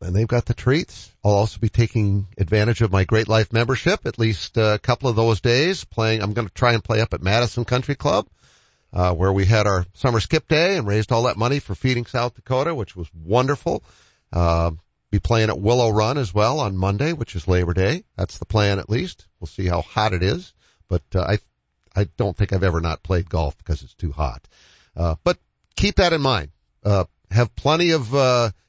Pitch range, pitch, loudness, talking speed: 95-120 Hz, 110 Hz, -21 LUFS, 220 wpm